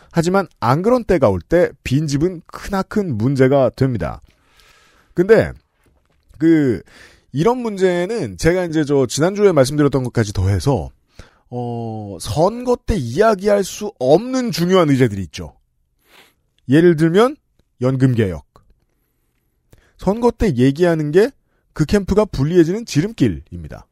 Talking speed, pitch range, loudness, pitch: 255 characters per minute, 120-195 Hz, -17 LUFS, 150 Hz